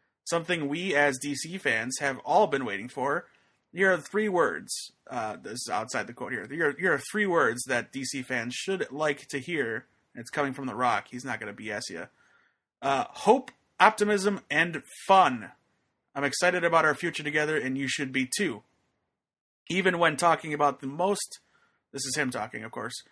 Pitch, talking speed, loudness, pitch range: 150 Hz, 190 wpm, -28 LUFS, 135-180 Hz